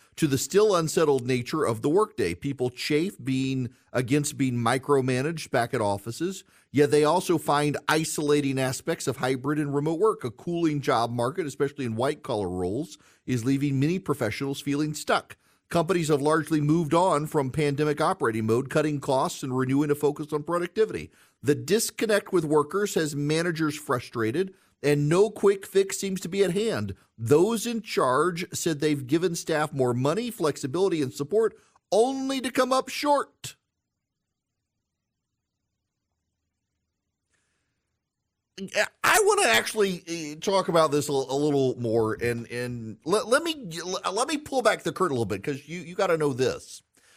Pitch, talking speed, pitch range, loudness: 150 Hz, 155 wpm, 130-180 Hz, -26 LUFS